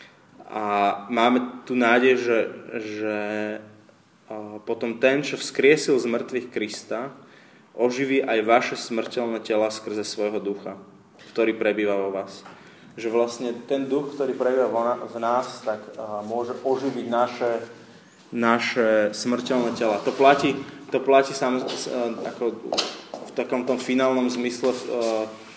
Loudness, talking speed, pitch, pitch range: -24 LUFS, 130 wpm, 120 Hz, 110-125 Hz